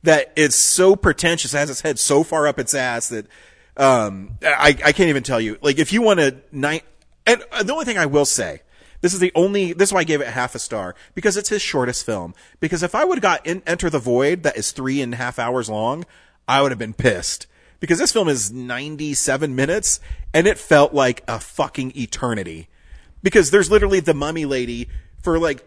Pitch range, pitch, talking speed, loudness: 125-170 Hz, 145 Hz, 220 wpm, -18 LUFS